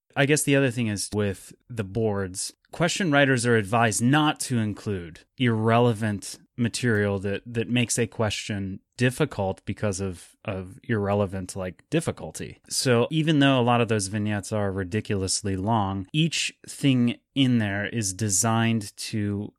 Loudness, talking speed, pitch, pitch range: -25 LUFS, 145 wpm, 110 Hz, 100-125 Hz